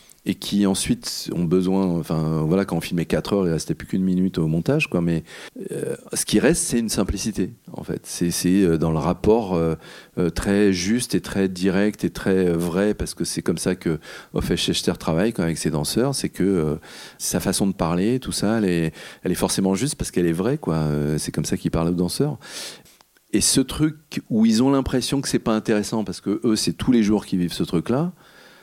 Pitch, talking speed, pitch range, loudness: 95 Hz, 220 wpm, 85-115 Hz, -22 LUFS